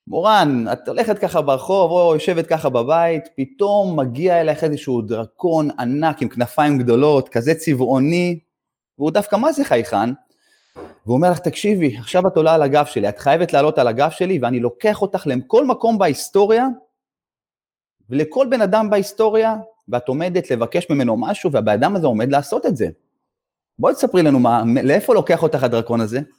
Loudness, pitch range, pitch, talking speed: -17 LUFS, 130-200 Hz, 160 Hz, 165 wpm